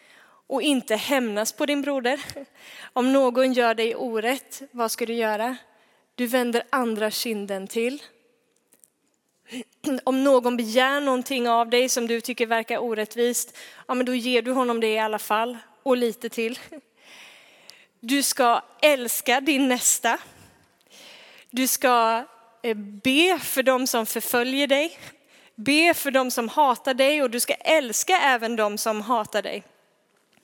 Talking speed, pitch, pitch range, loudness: 140 wpm, 245 Hz, 230-265 Hz, -23 LUFS